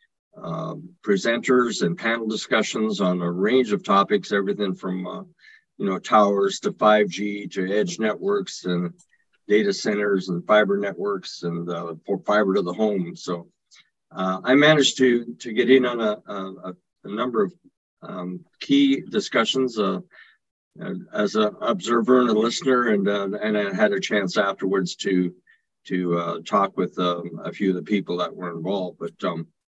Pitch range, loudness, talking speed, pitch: 95-130 Hz, -22 LUFS, 165 wpm, 105 Hz